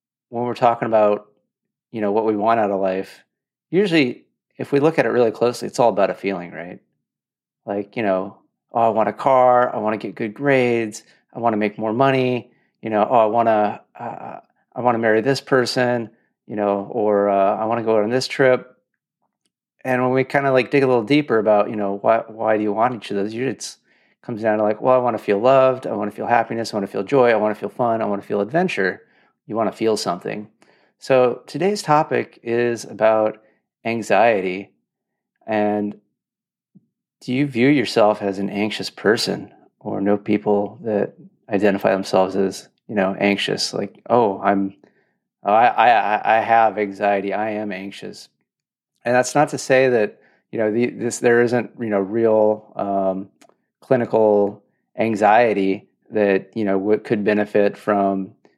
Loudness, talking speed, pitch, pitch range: -19 LUFS, 190 wpm, 110 Hz, 100-120 Hz